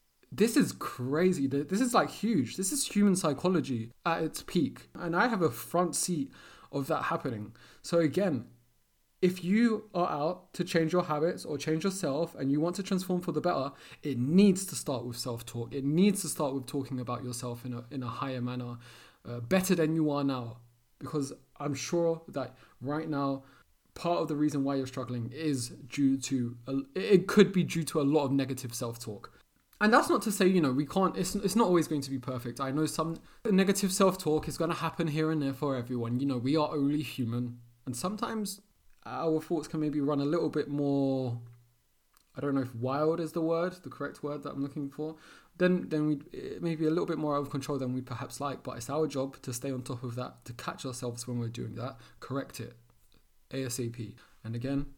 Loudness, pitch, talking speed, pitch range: -31 LUFS, 145 Hz, 215 wpm, 130-170 Hz